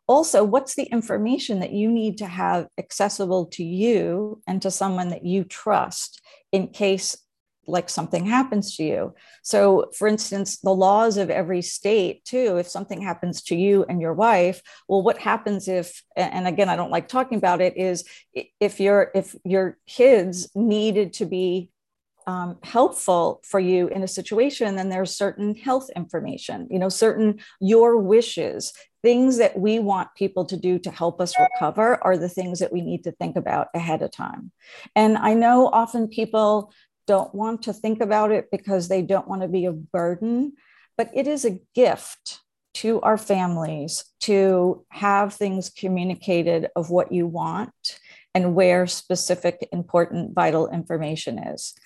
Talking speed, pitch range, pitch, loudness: 165 wpm, 180-220 Hz, 195 Hz, -22 LUFS